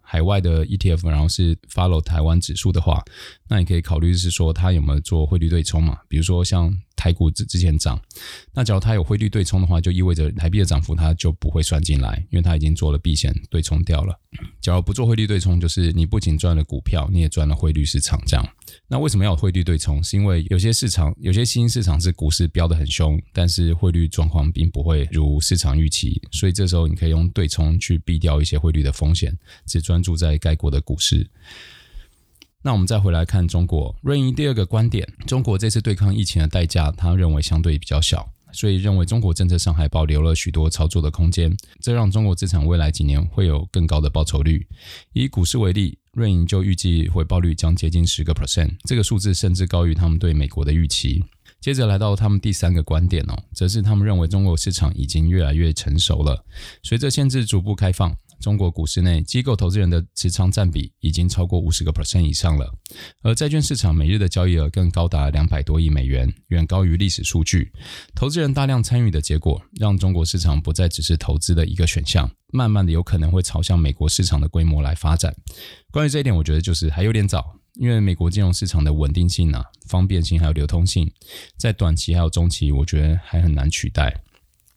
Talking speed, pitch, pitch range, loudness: 350 characters per minute, 85 Hz, 80-95 Hz, -20 LUFS